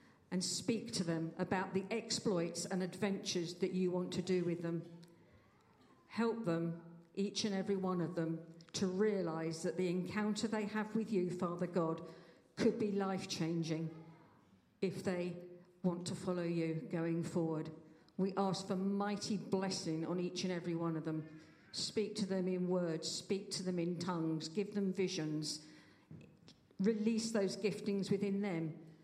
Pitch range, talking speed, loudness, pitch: 165-195 Hz, 160 wpm, -39 LUFS, 180 Hz